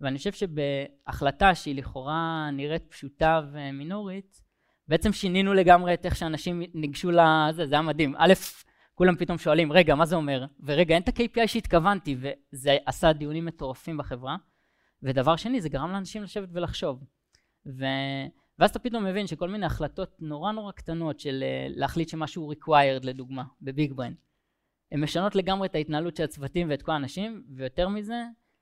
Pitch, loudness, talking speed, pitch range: 160 Hz, -26 LUFS, 155 wpm, 140-185 Hz